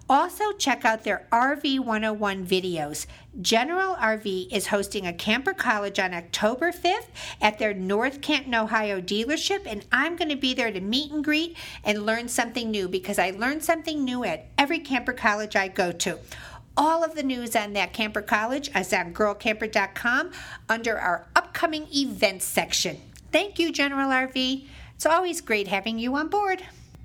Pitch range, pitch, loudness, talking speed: 210-300 Hz, 235 Hz, -25 LUFS, 170 wpm